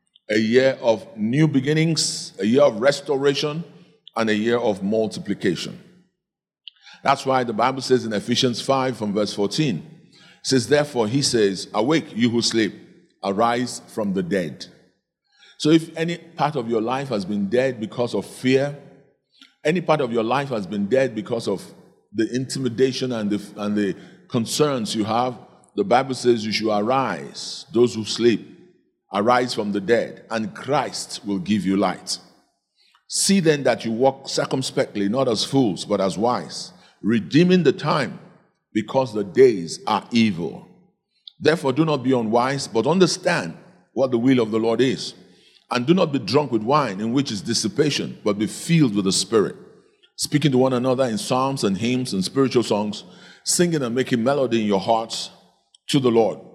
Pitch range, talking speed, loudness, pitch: 110-150 Hz, 170 wpm, -21 LUFS, 130 Hz